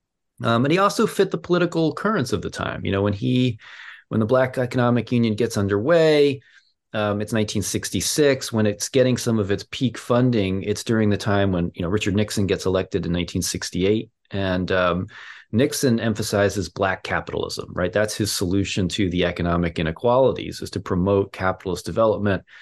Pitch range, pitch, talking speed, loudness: 95-120 Hz, 105 Hz, 170 wpm, -22 LUFS